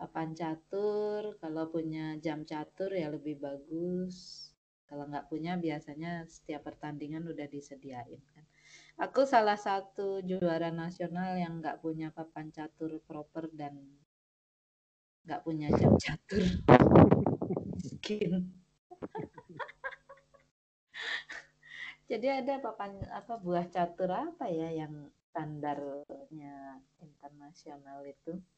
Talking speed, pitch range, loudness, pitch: 95 wpm, 150-180 Hz, -33 LUFS, 160 Hz